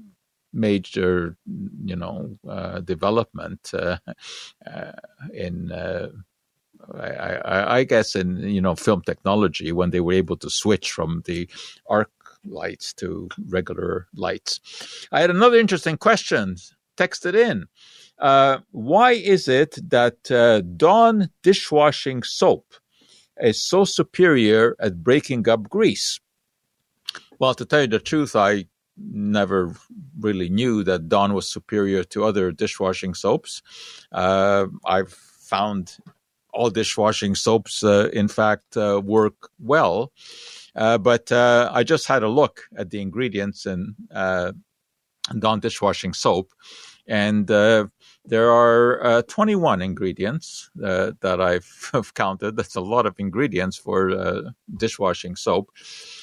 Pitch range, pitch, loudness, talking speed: 95-130 Hz, 110 Hz, -21 LUFS, 125 wpm